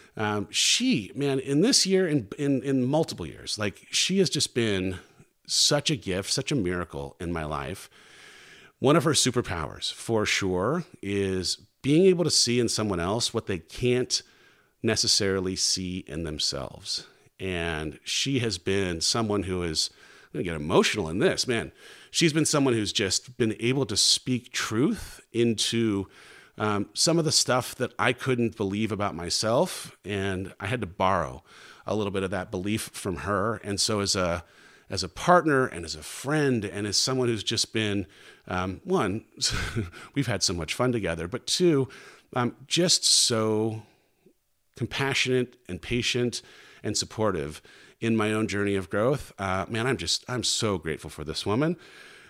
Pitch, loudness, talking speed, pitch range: 110 Hz, -26 LUFS, 170 wpm, 95-130 Hz